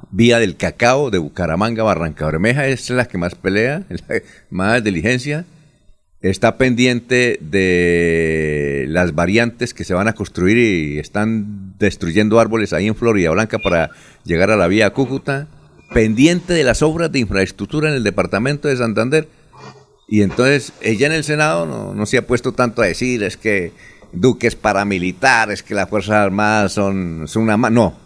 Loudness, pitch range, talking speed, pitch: -16 LUFS, 95-125 Hz, 170 wpm, 110 Hz